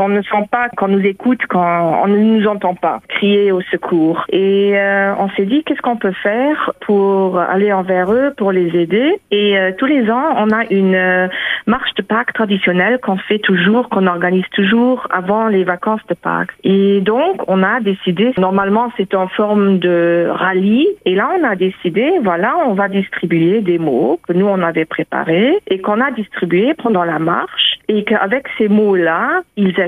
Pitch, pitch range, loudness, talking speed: 200 Hz, 185-225 Hz, -14 LUFS, 190 wpm